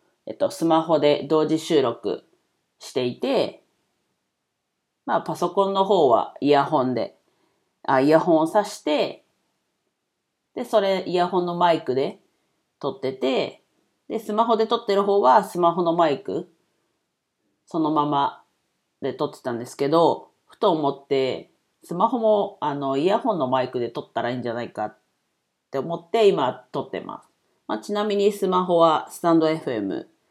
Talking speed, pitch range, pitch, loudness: 285 characters per minute, 140-200 Hz, 165 Hz, -22 LUFS